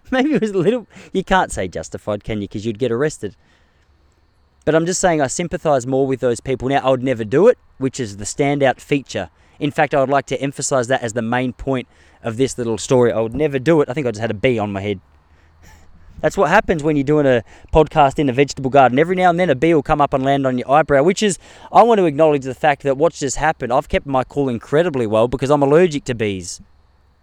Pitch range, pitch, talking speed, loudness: 110-155 Hz, 135 Hz, 255 wpm, -17 LUFS